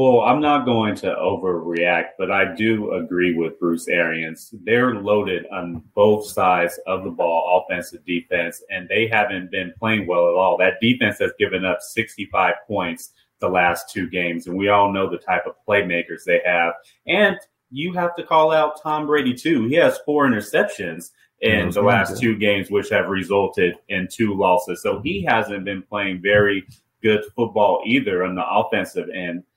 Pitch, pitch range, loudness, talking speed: 100 Hz, 90-120 Hz, -20 LUFS, 180 wpm